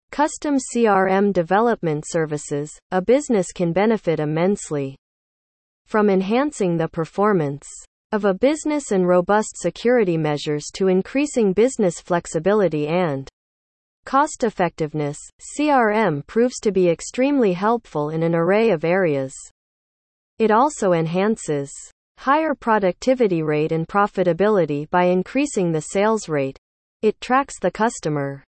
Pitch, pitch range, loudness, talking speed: 185 Hz, 160-225 Hz, -20 LUFS, 115 wpm